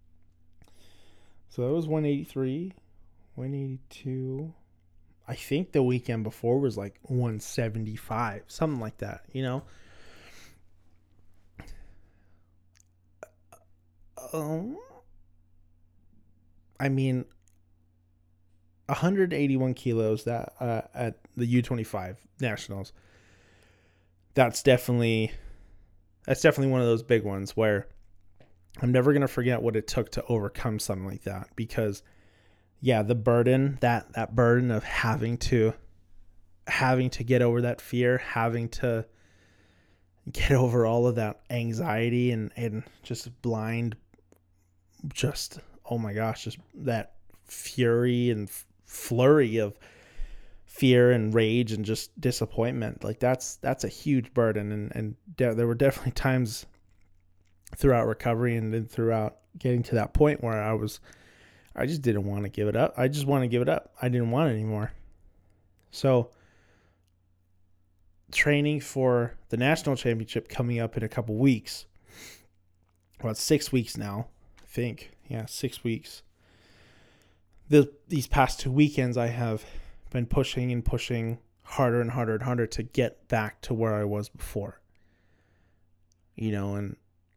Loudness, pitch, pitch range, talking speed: -28 LUFS, 110 Hz, 90-125 Hz, 130 wpm